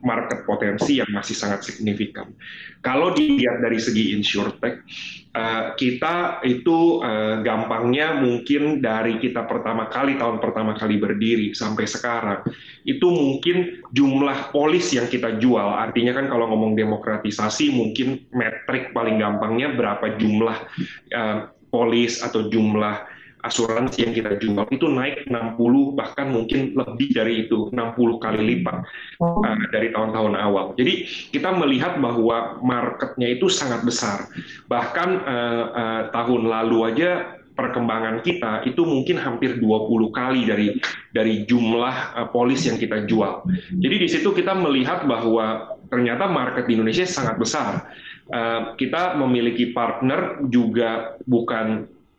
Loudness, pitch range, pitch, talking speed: -21 LUFS, 110-130 Hz, 115 Hz, 130 wpm